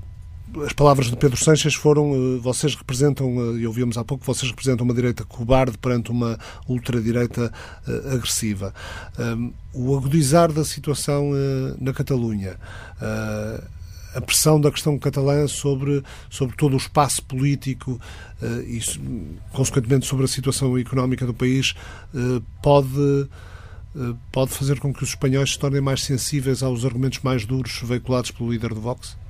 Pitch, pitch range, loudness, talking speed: 125 Hz, 115-140 Hz, -22 LUFS, 135 wpm